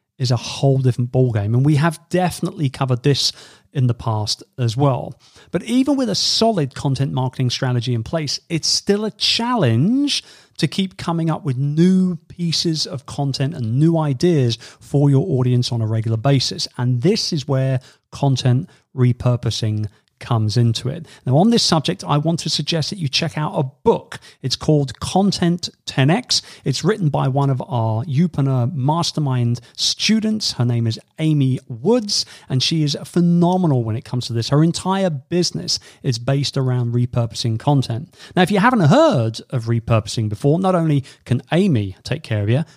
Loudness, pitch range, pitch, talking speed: -19 LUFS, 125-165 Hz, 140 Hz, 175 wpm